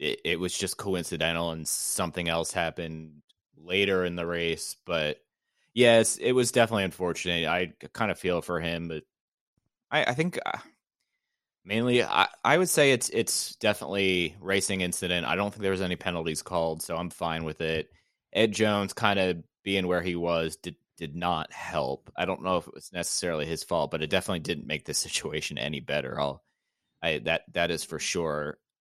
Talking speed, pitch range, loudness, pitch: 185 wpm, 85-100 Hz, -28 LUFS, 90 Hz